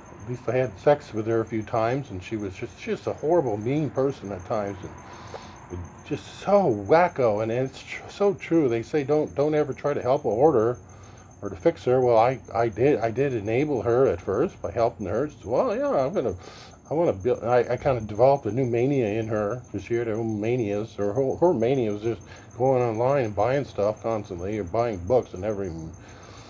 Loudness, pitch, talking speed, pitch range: -25 LUFS, 115 Hz, 220 wpm, 105-130 Hz